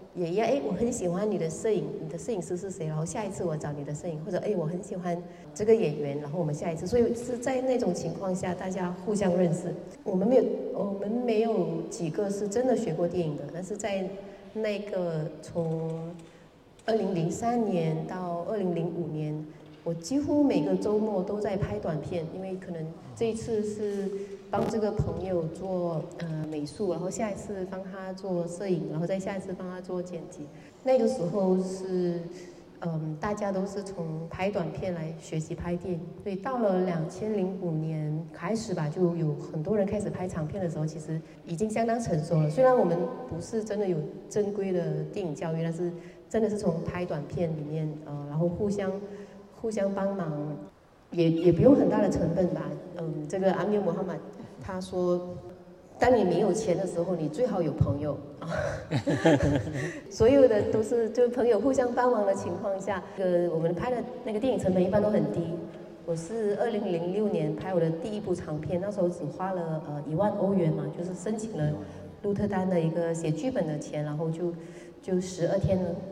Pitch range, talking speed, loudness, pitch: 165-205 Hz, 285 characters per minute, -29 LUFS, 180 Hz